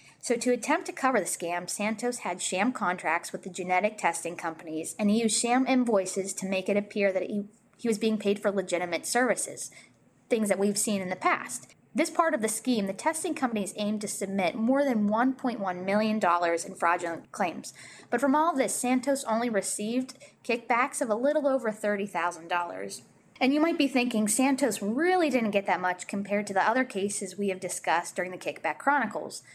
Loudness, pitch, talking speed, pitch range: -28 LUFS, 210 Hz, 195 wpm, 185-250 Hz